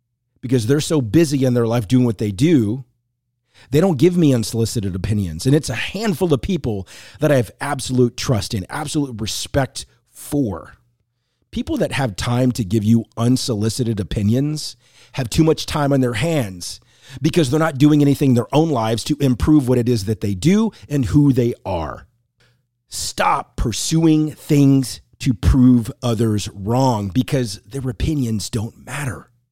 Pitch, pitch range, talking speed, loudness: 125 Hz, 115-145 Hz, 165 wpm, -18 LUFS